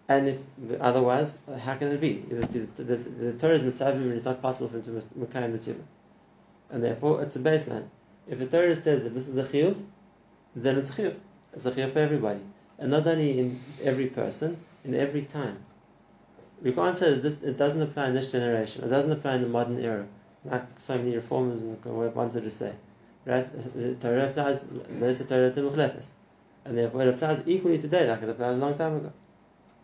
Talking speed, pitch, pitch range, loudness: 195 wpm, 130 Hz, 120-145 Hz, -28 LUFS